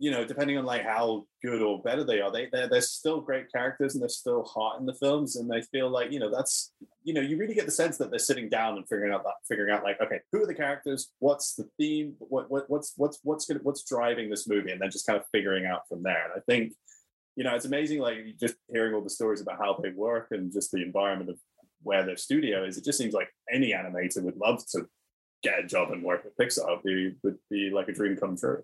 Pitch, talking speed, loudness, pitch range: 125 Hz, 270 wpm, -30 LUFS, 105-145 Hz